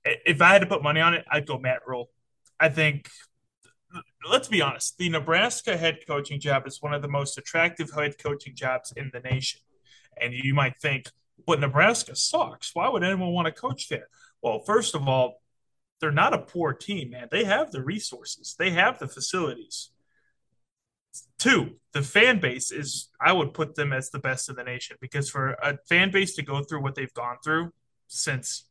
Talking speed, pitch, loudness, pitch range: 200 wpm, 145 Hz, -25 LUFS, 130-160 Hz